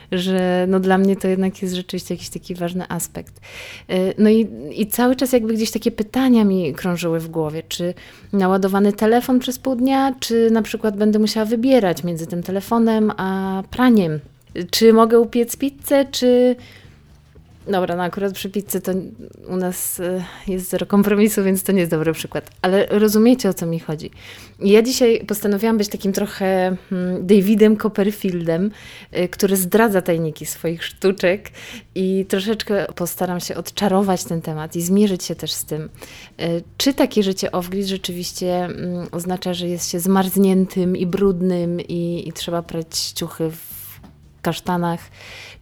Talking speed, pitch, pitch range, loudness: 150 wpm, 190 Hz, 175-215 Hz, -19 LUFS